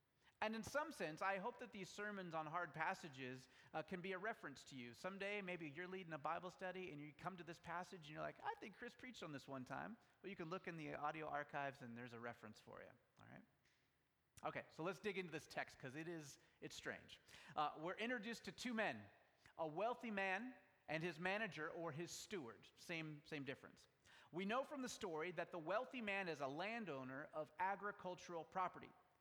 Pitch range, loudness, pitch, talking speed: 155-195 Hz, -50 LUFS, 175 Hz, 215 wpm